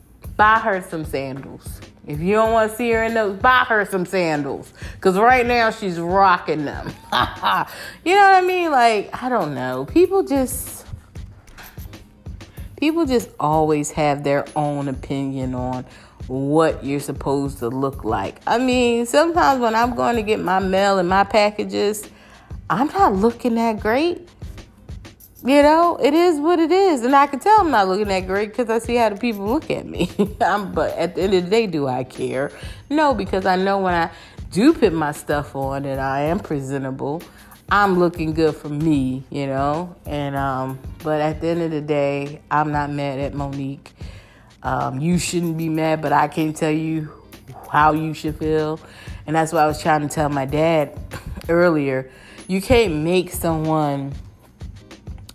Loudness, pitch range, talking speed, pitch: -19 LUFS, 140-220 Hz, 180 wpm, 160 Hz